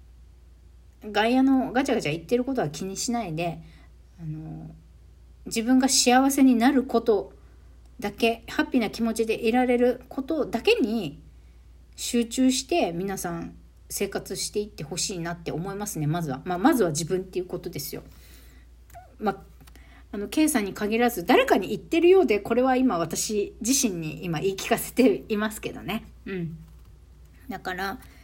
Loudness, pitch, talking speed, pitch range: -25 LUFS, 200 Hz, 305 characters per minute, 150-245 Hz